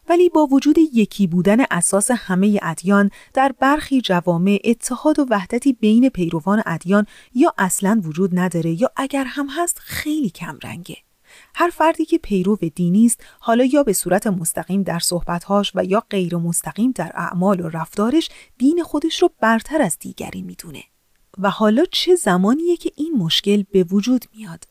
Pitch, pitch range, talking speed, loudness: 210 Hz, 180-275 Hz, 160 wpm, -18 LUFS